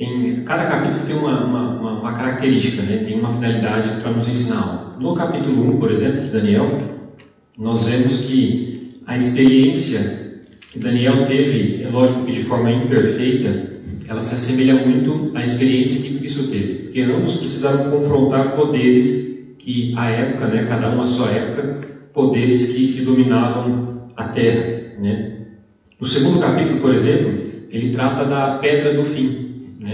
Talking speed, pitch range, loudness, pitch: 150 wpm, 120-130 Hz, -18 LUFS, 125 Hz